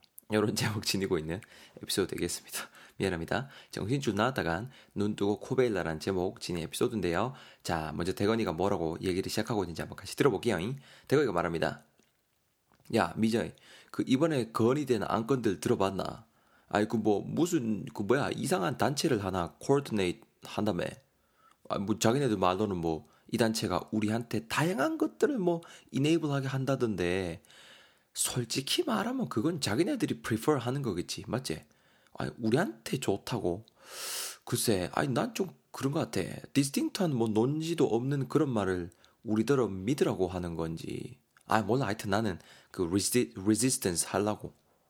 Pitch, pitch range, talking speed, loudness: 110 Hz, 95-130 Hz, 345 characters per minute, -31 LUFS